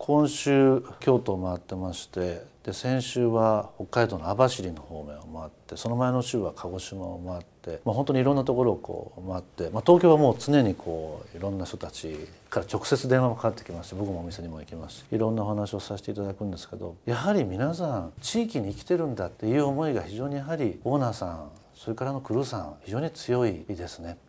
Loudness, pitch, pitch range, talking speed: -27 LUFS, 110 Hz, 90-130 Hz, 430 characters per minute